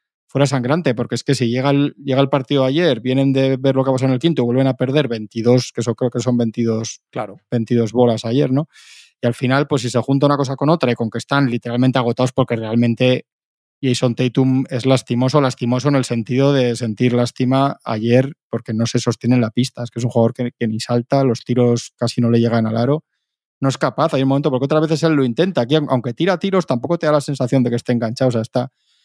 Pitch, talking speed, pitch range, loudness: 125 Hz, 250 wpm, 120-135 Hz, -18 LUFS